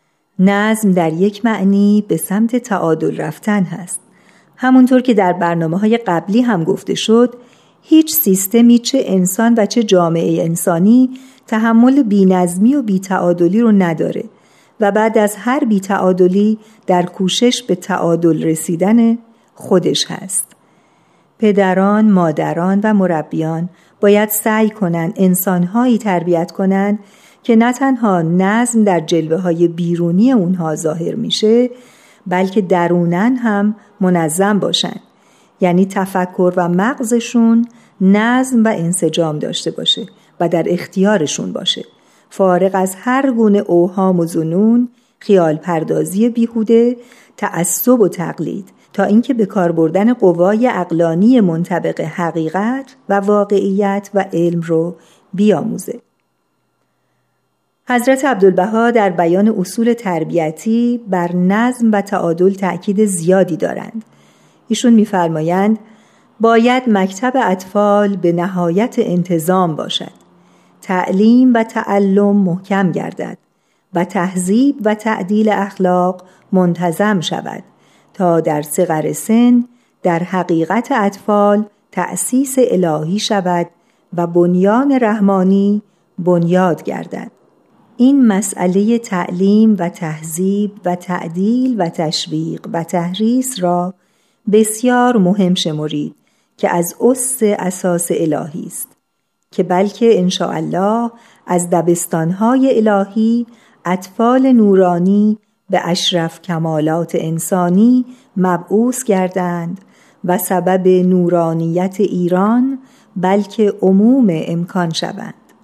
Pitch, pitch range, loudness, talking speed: 195 Hz, 175-225 Hz, -14 LUFS, 105 wpm